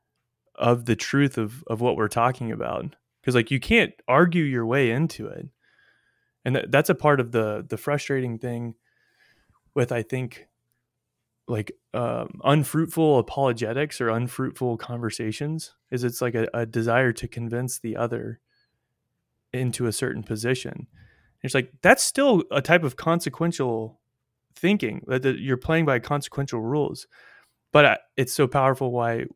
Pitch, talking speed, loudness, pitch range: 130 Hz, 155 wpm, -24 LUFS, 120-145 Hz